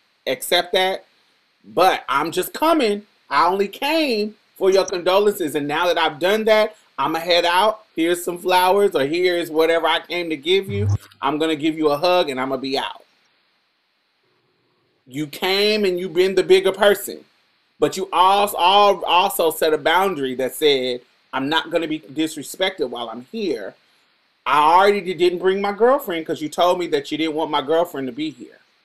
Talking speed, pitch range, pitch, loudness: 185 wpm, 155-200 Hz, 180 Hz, -19 LUFS